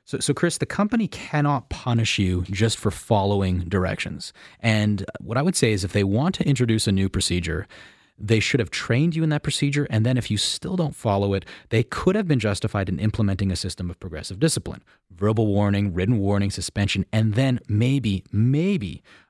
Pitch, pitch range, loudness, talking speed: 110 Hz, 100-140 Hz, -23 LUFS, 195 wpm